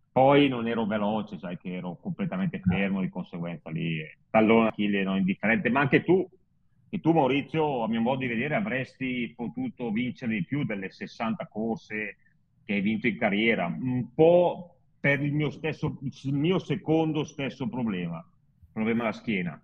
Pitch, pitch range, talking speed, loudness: 130 Hz, 105-160 Hz, 175 wpm, -27 LUFS